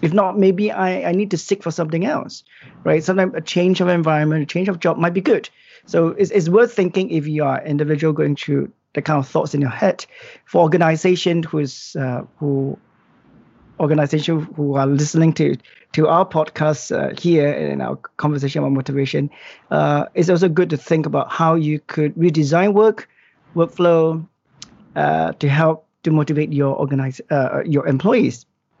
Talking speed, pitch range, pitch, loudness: 180 wpm, 145-180 Hz, 160 Hz, -18 LUFS